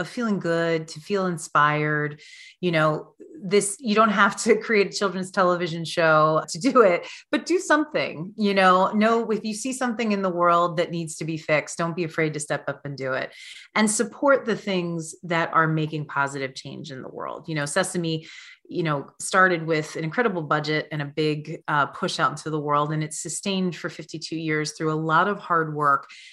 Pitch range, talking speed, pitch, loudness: 155-205 Hz, 205 wpm, 170 Hz, -23 LUFS